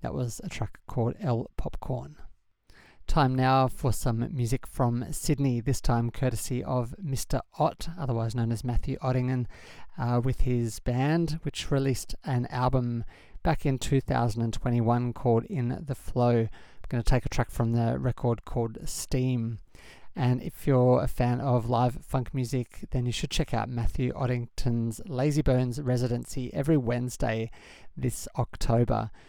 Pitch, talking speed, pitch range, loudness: 125 Hz, 150 wpm, 115-130 Hz, -29 LUFS